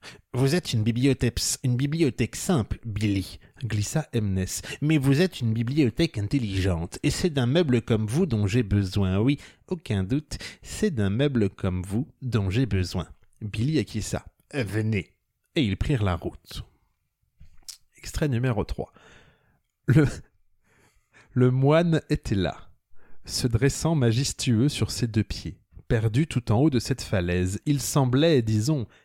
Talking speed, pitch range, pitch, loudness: 145 wpm, 100-140 Hz, 115 Hz, -25 LUFS